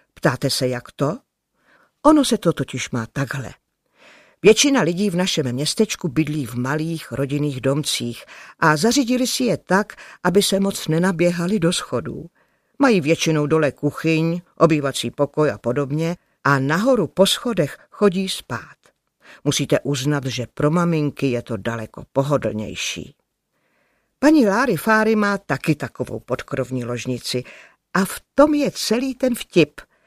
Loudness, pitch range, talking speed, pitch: -20 LUFS, 135-195 Hz, 140 wpm, 155 Hz